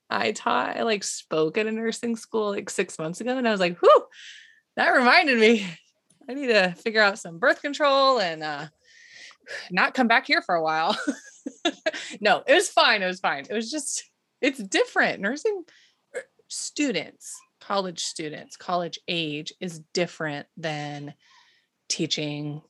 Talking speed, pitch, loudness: 160 wpm, 225 Hz, -24 LUFS